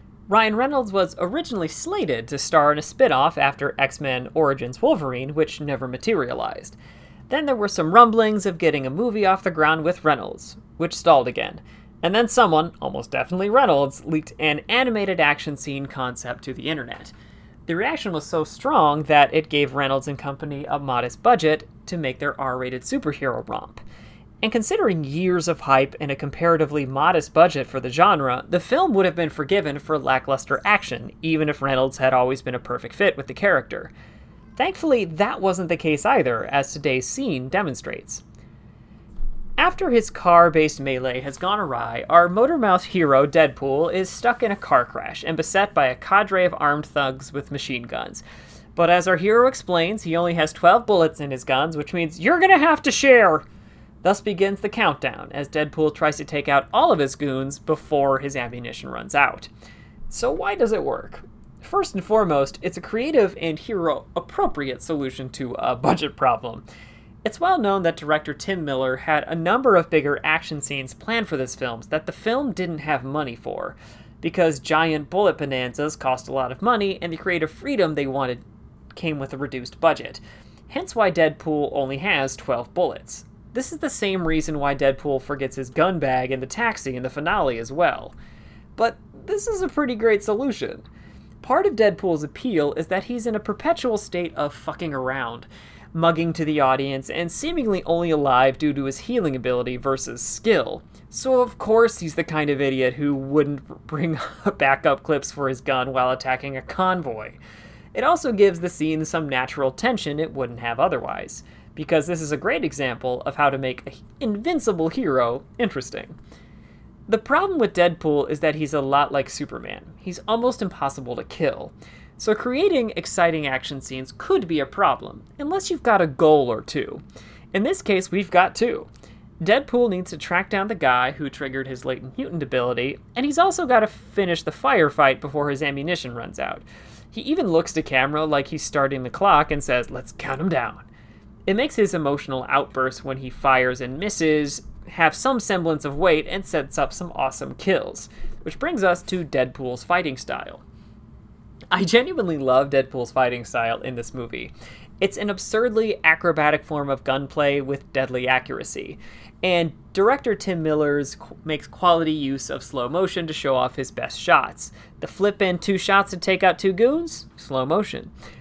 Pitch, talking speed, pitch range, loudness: 155 Hz, 180 wpm, 135-195 Hz, -22 LUFS